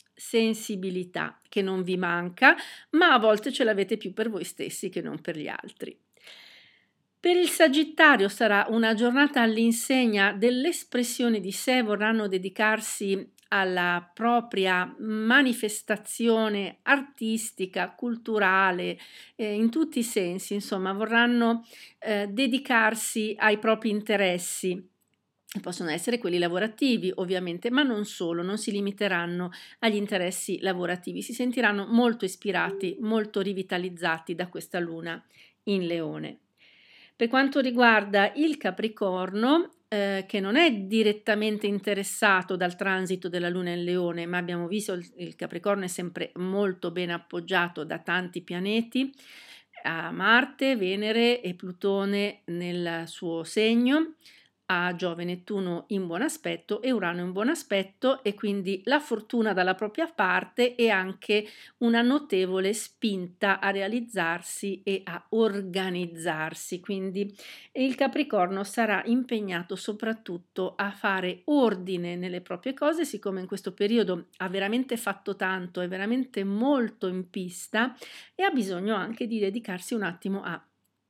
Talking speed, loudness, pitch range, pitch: 130 wpm, -27 LUFS, 185-230 Hz, 205 Hz